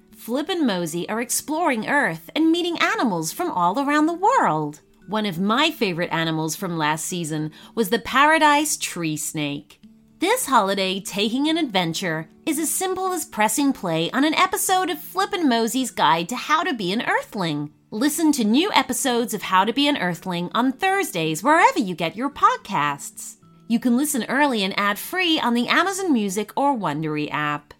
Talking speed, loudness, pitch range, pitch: 180 wpm, -21 LUFS, 180-305 Hz, 235 Hz